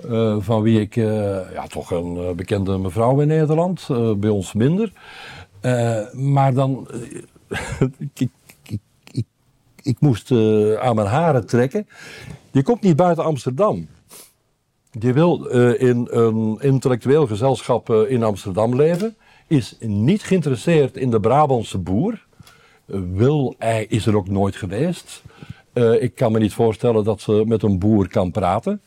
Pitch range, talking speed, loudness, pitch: 110-140 Hz, 160 wpm, -19 LUFS, 120 Hz